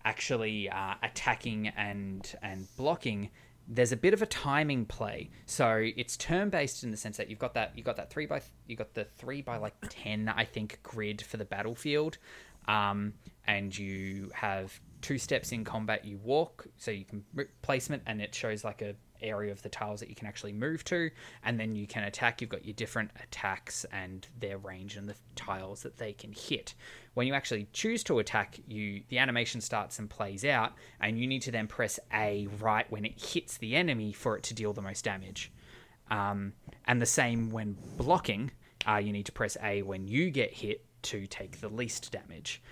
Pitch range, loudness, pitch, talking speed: 100-120 Hz, -34 LUFS, 110 Hz, 205 wpm